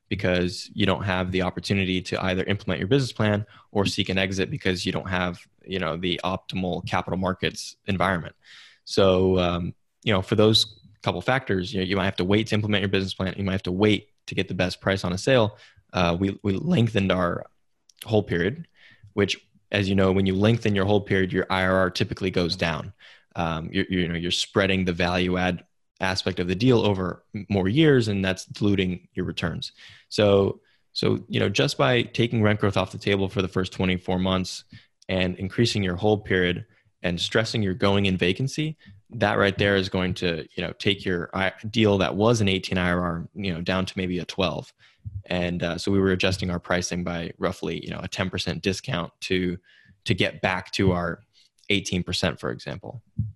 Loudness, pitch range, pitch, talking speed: -24 LUFS, 90-105 Hz, 95 Hz, 200 wpm